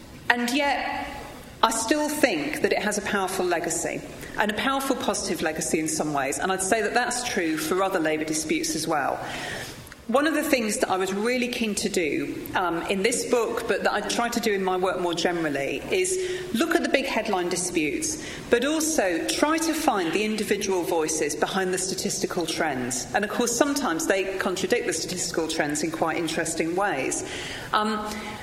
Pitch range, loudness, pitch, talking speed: 180-270 Hz, -25 LUFS, 210 Hz, 190 wpm